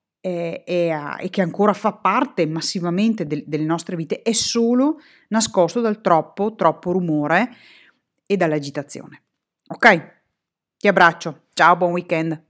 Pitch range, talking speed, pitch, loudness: 165-215 Hz, 130 wpm, 180 Hz, -19 LUFS